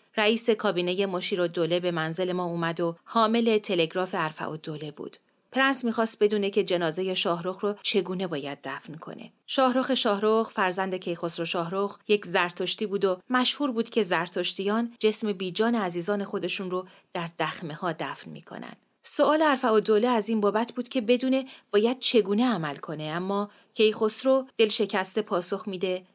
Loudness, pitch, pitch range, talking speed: -24 LUFS, 200 Hz, 180-225 Hz, 160 wpm